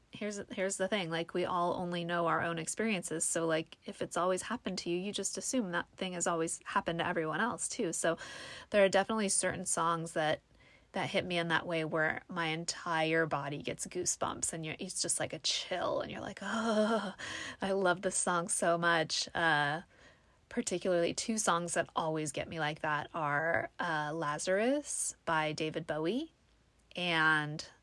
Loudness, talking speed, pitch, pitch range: -33 LUFS, 185 wpm, 170 Hz, 160-190 Hz